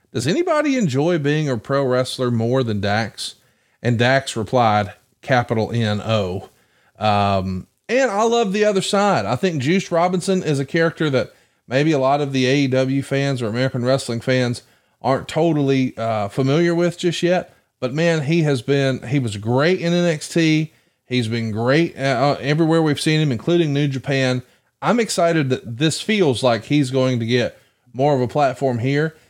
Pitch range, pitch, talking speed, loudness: 125-165 Hz, 135 Hz, 175 wpm, -19 LUFS